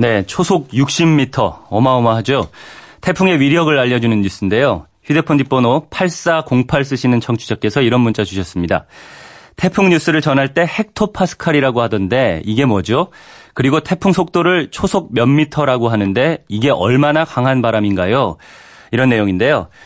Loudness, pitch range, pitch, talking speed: -14 LUFS, 115-165 Hz, 135 Hz, 325 characters per minute